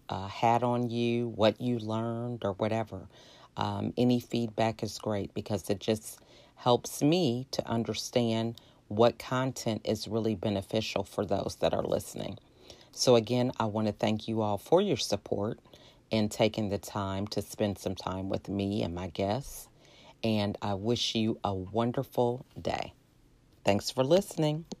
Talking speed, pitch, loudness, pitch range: 155 wpm, 110 Hz, -31 LUFS, 105-120 Hz